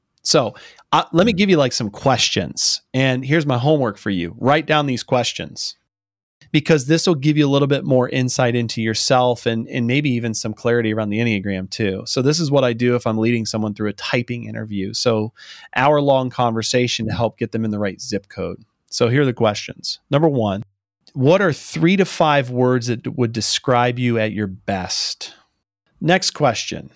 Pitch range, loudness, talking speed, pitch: 110-140 Hz, -19 LUFS, 200 wpm, 120 Hz